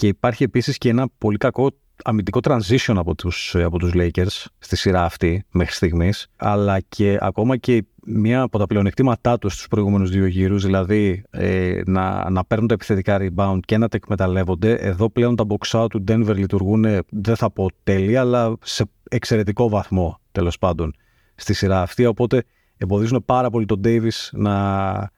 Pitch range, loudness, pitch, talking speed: 95-115 Hz, -20 LUFS, 105 Hz, 170 wpm